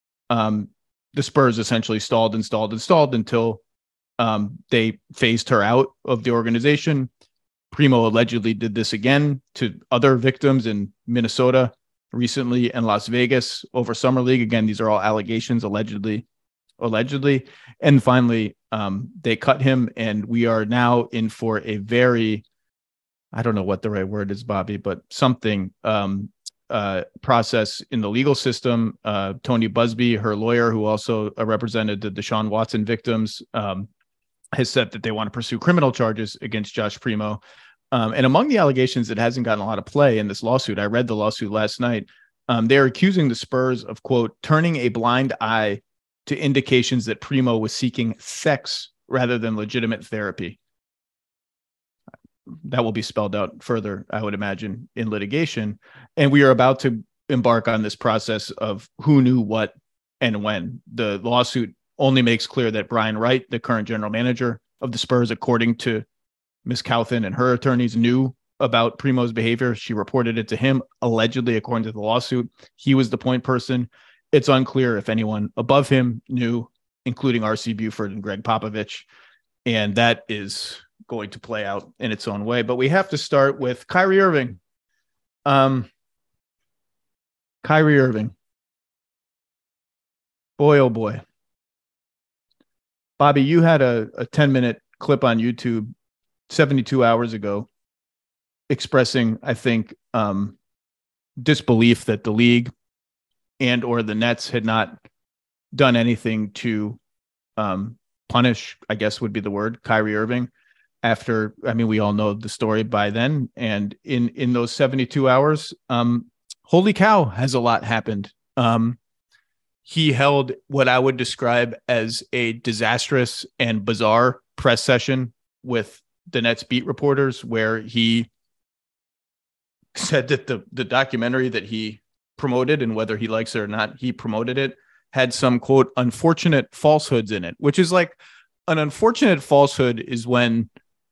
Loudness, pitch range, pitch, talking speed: -21 LUFS, 110-130 Hz, 115 Hz, 155 wpm